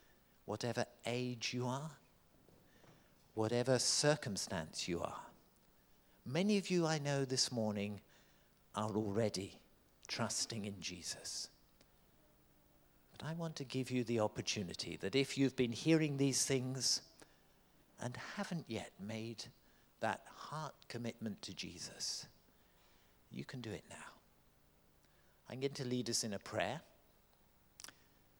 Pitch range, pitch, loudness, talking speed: 110-135 Hz, 125 Hz, -40 LUFS, 120 wpm